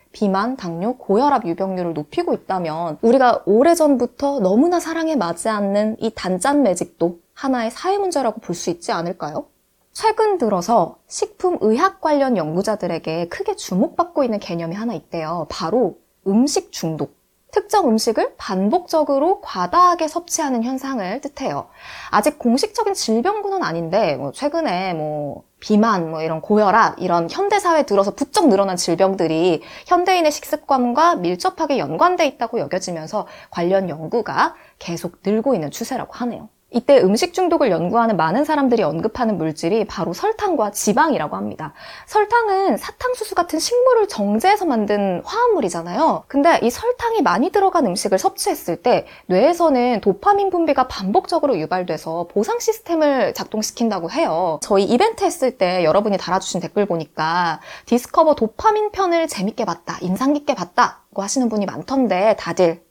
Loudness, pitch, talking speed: -19 LUFS, 240 Hz, 355 characters per minute